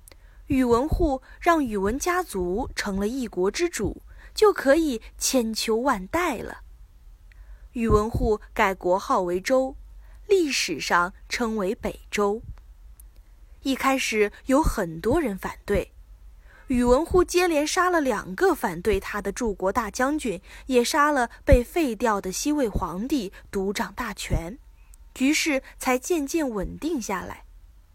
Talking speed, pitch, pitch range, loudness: 190 characters per minute, 245 Hz, 200-290 Hz, -24 LUFS